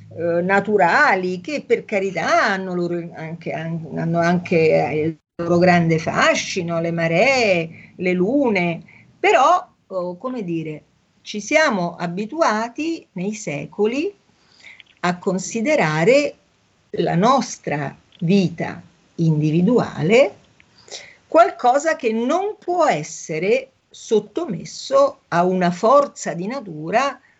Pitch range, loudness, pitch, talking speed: 170-255 Hz, -19 LUFS, 190 Hz, 95 wpm